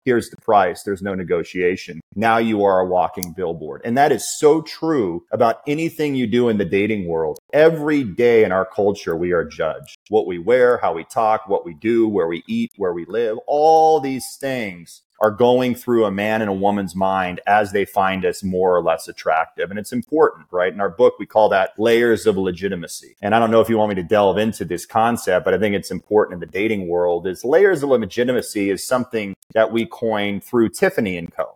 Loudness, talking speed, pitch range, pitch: -19 LUFS, 220 wpm, 95-150 Hz, 110 Hz